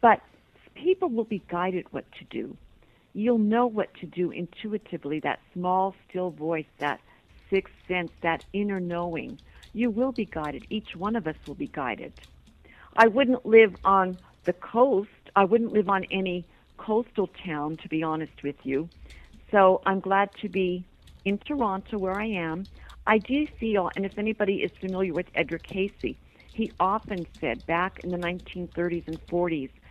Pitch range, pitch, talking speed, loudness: 170-210 Hz, 185 Hz, 165 wpm, -27 LUFS